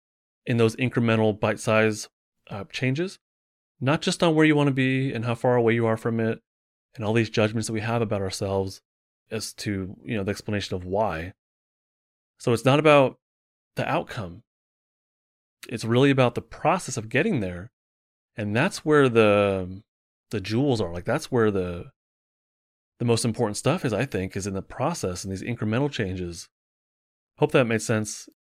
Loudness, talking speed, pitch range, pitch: -24 LUFS, 175 wpm, 95-125 Hz, 110 Hz